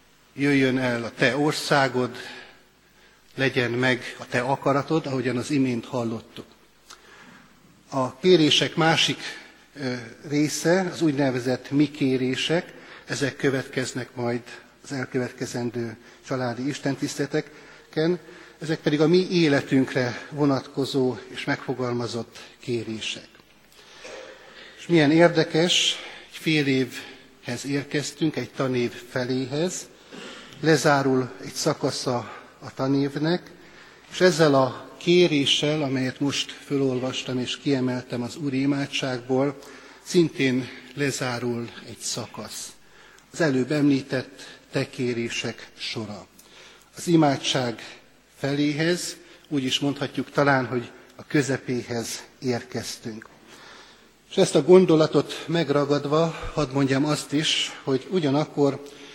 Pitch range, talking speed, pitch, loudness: 125-150 Hz, 95 wpm, 140 Hz, -24 LUFS